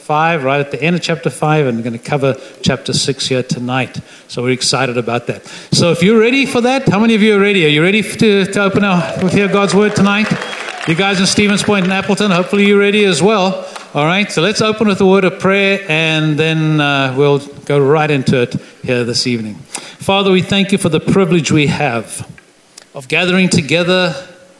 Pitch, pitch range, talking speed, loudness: 175 Hz, 145-200 Hz, 220 wpm, -13 LUFS